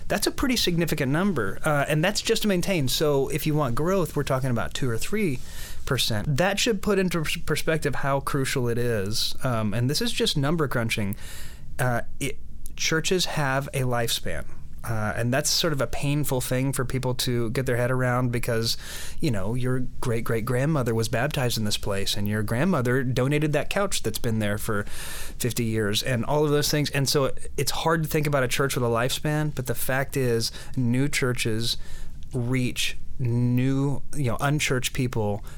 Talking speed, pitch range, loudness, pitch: 190 wpm, 115-150 Hz, -25 LUFS, 130 Hz